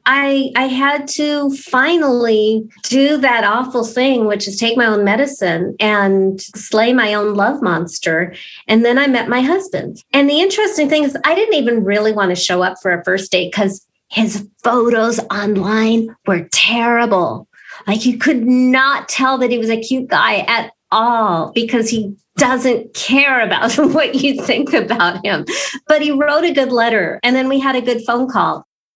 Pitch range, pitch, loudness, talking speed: 210-270 Hz, 235 Hz, -14 LUFS, 180 wpm